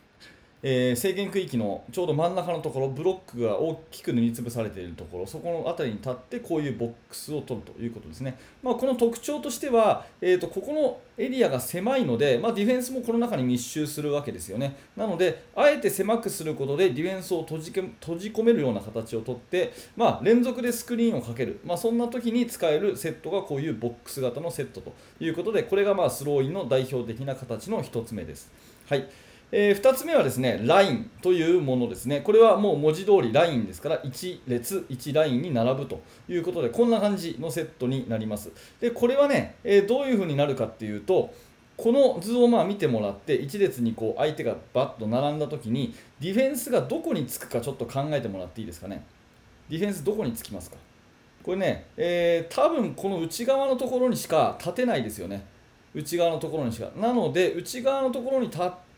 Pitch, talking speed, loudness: 165 Hz, 430 characters per minute, -26 LUFS